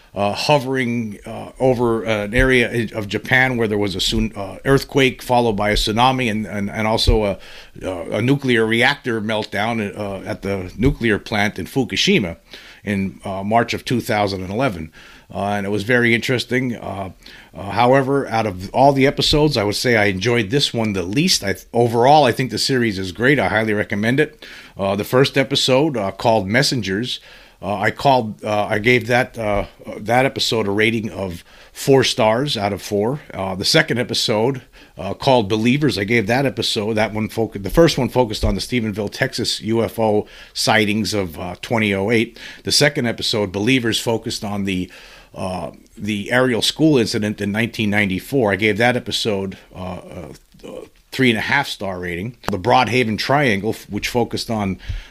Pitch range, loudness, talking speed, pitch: 100-125 Hz, -18 LUFS, 175 wpm, 110 Hz